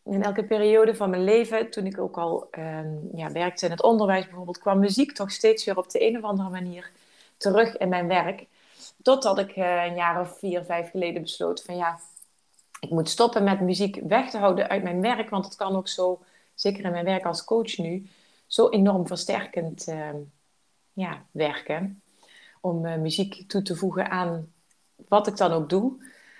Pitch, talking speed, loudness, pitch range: 190 Hz, 195 wpm, -25 LUFS, 175-205 Hz